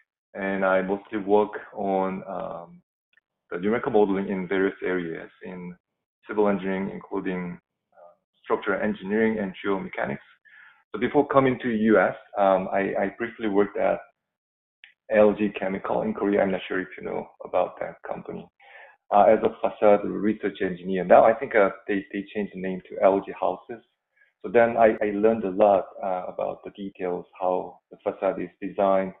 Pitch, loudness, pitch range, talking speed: 100 Hz, -24 LUFS, 95-105 Hz, 165 wpm